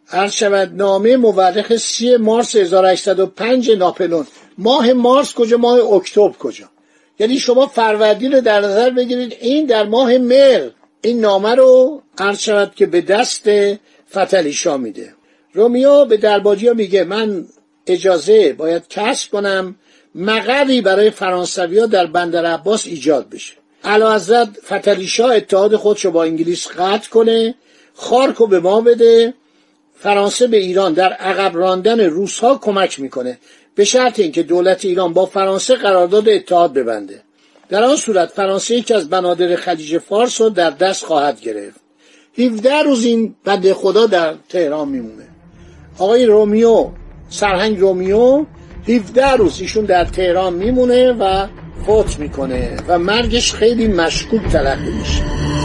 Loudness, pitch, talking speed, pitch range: -14 LUFS, 205 Hz, 135 wpm, 185-235 Hz